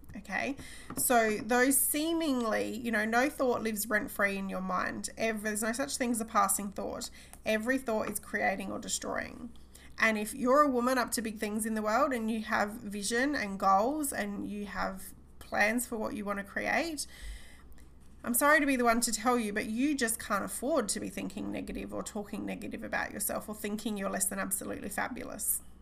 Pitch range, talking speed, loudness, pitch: 205-250 Hz, 200 wpm, -31 LUFS, 225 Hz